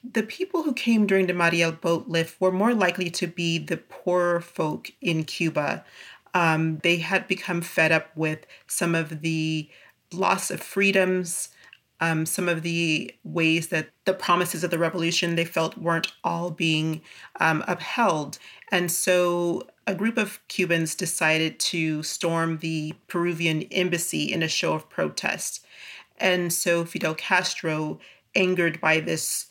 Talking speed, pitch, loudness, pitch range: 150 wpm, 170 Hz, -24 LUFS, 160-185 Hz